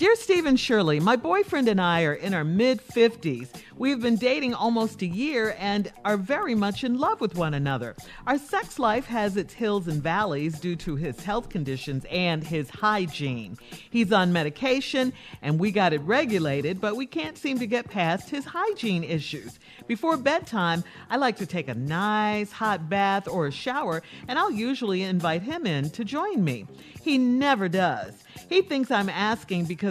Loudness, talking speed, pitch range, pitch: -26 LUFS, 185 wpm, 170-250 Hz, 205 Hz